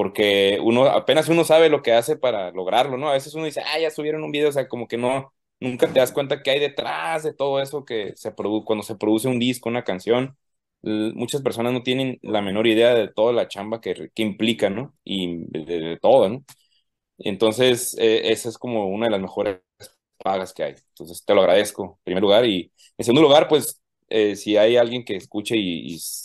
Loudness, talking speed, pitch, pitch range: -21 LUFS, 220 wpm, 120 Hz, 110-135 Hz